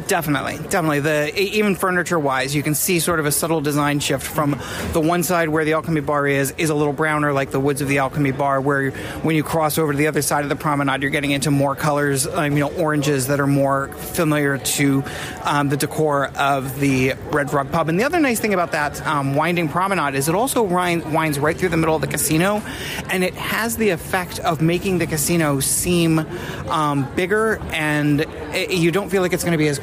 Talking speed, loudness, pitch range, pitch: 230 wpm, -19 LUFS, 145-170 Hz, 150 Hz